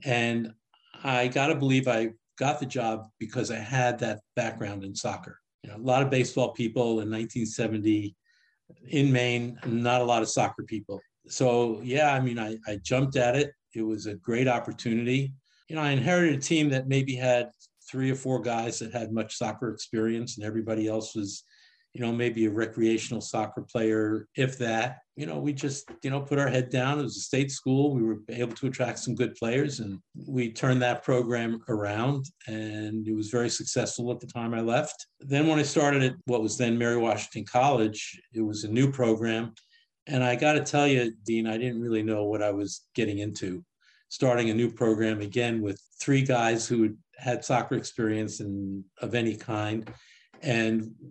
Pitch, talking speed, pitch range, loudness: 120 Hz, 195 wpm, 110-130 Hz, -28 LUFS